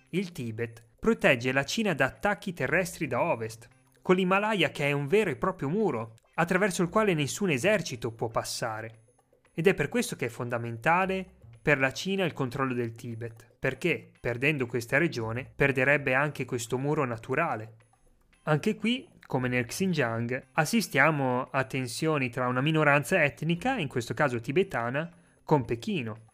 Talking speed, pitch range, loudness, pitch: 155 wpm, 125-180 Hz, -28 LUFS, 140 Hz